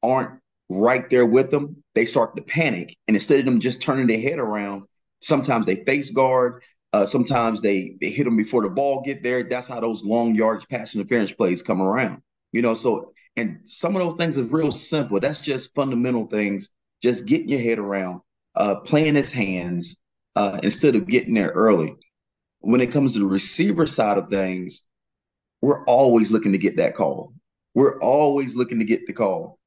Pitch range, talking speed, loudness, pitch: 105-140 Hz, 195 wpm, -21 LUFS, 125 Hz